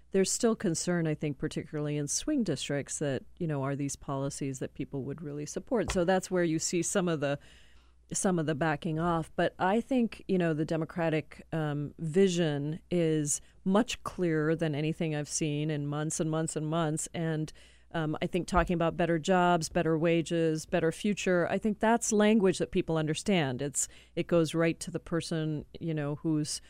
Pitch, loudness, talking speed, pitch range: 165 Hz, -30 LUFS, 190 wpm, 150-175 Hz